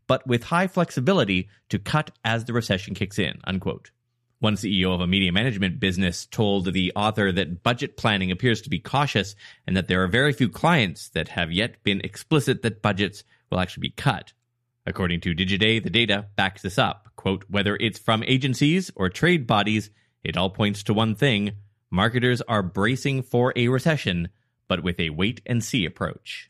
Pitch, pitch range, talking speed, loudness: 105 Hz, 95-120 Hz, 185 wpm, -23 LUFS